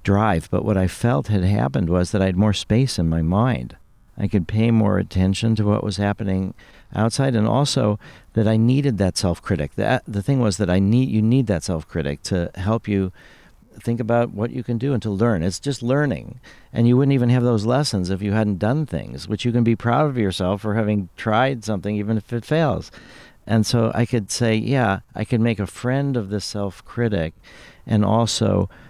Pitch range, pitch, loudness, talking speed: 100-120 Hz, 110 Hz, -21 LUFS, 210 wpm